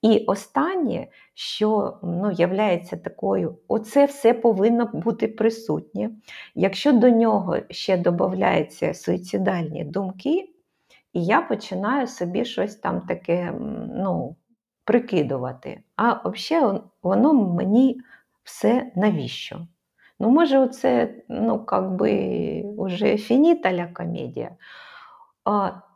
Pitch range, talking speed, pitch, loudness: 185-240 Hz, 95 wpm, 220 Hz, -22 LUFS